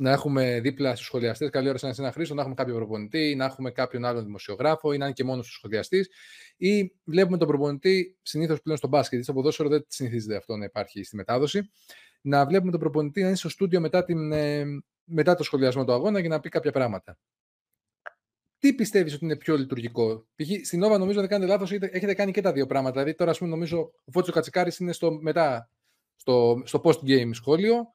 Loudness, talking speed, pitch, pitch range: -26 LUFS, 215 wpm, 150 Hz, 130-180 Hz